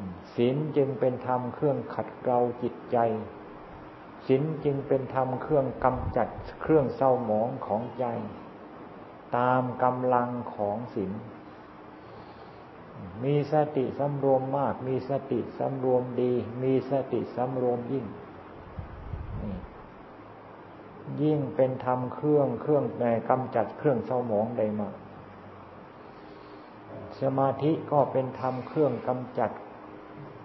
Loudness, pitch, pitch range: -28 LUFS, 125 Hz, 110-135 Hz